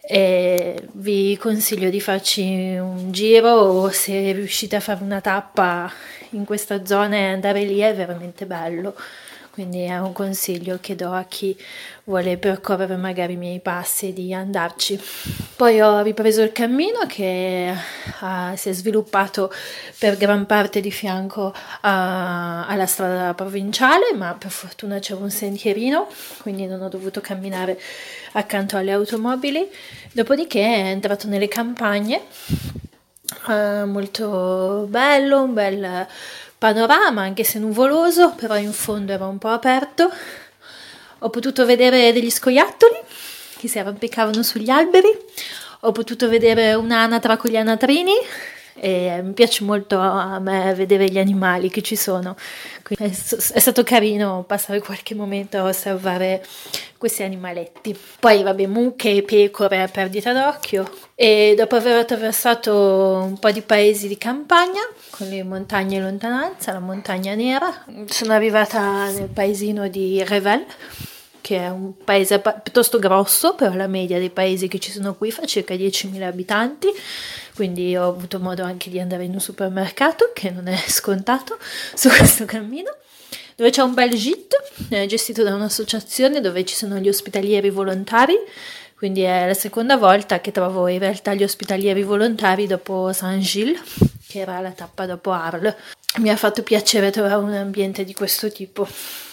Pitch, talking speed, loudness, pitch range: 205 Hz, 150 wpm, -19 LUFS, 190-225 Hz